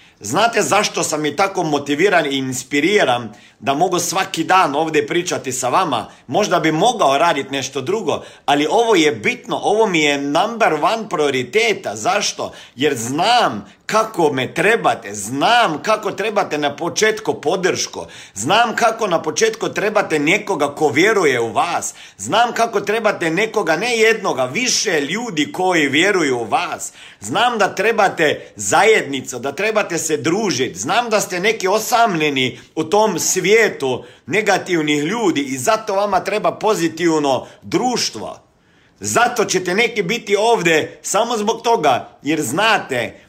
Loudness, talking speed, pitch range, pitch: -17 LUFS, 140 wpm, 150-215 Hz, 180 Hz